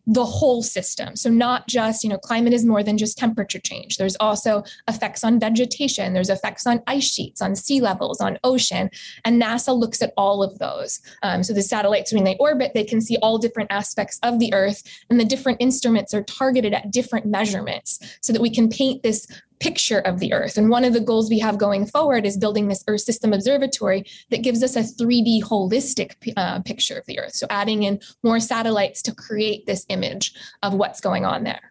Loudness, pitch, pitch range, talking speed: -20 LUFS, 225 Hz, 205-245 Hz, 210 wpm